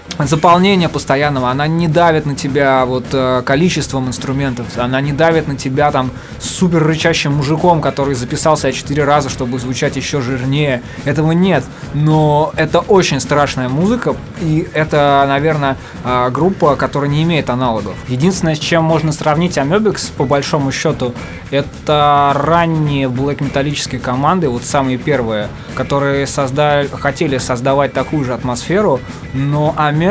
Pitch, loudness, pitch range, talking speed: 145 Hz, -14 LUFS, 130-155 Hz, 135 wpm